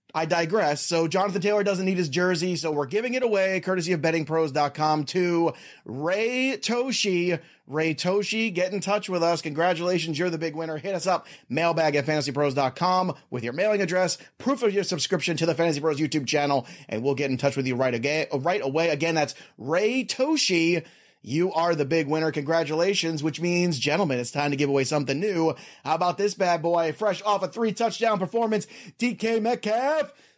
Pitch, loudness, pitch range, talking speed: 170 Hz, -25 LUFS, 155-200 Hz, 190 wpm